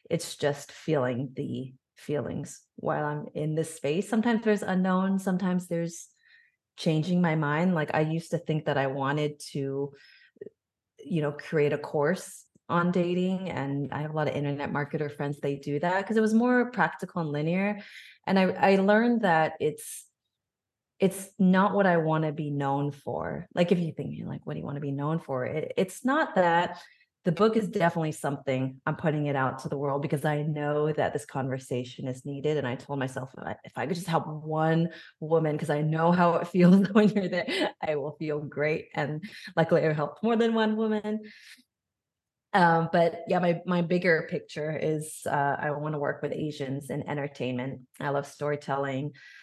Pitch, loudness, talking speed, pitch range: 160 Hz, -28 LUFS, 190 wpm, 145-185 Hz